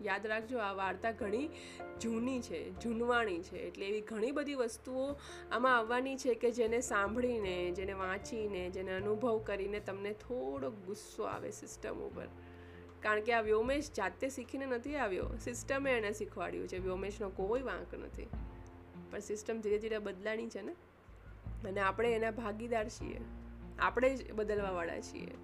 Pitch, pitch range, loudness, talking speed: 210 Hz, 185-235 Hz, -37 LUFS, 150 wpm